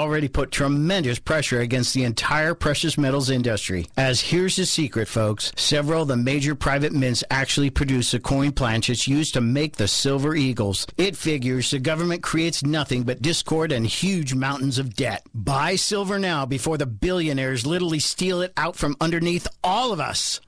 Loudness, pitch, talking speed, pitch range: -22 LUFS, 140 Hz, 175 wpm, 130-160 Hz